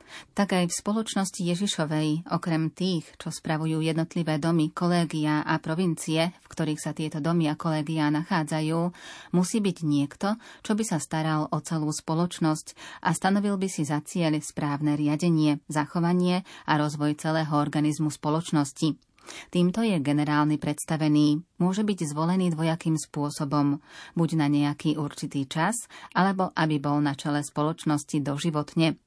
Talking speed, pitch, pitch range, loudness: 140 wpm, 160 Hz, 150-175 Hz, -27 LUFS